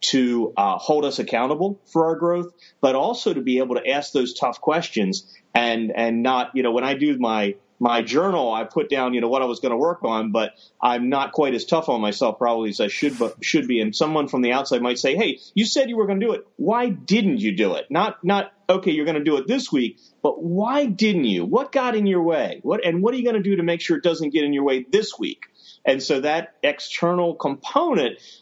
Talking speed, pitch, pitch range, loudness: 255 wpm, 155 Hz, 125-200 Hz, -21 LUFS